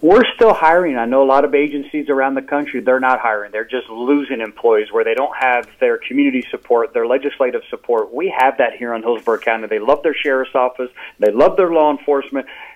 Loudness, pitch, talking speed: -16 LUFS, 145 Hz, 215 wpm